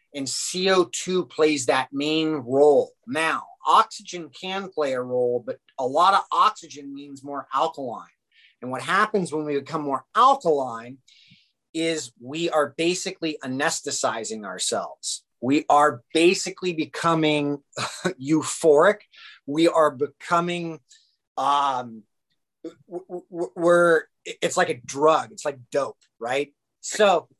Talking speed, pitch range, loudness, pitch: 120 wpm, 140-175 Hz, -23 LUFS, 155 Hz